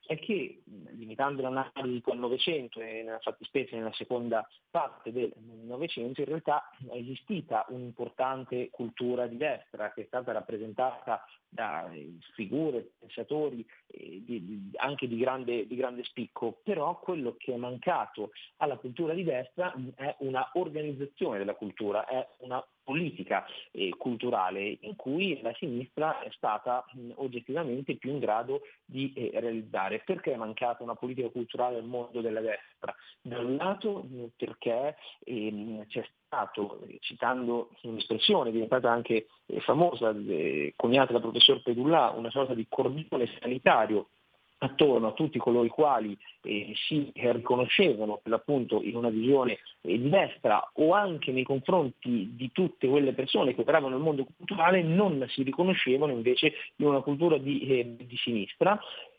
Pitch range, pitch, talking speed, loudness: 120-145 Hz, 125 Hz, 150 wpm, -30 LUFS